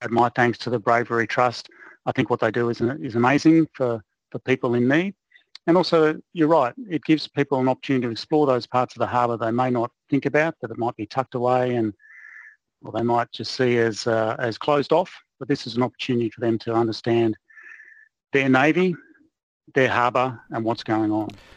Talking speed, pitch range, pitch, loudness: 210 wpm, 115-145 Hz, 125 Hz, -22 LUFS